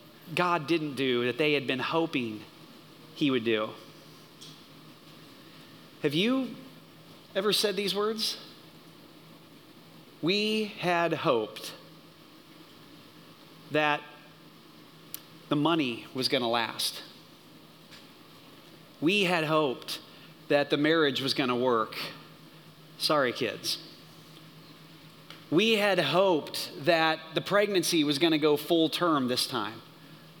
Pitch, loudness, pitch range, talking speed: 160 Hz, -28 LUFS, 150-180 Hz, 105 wpm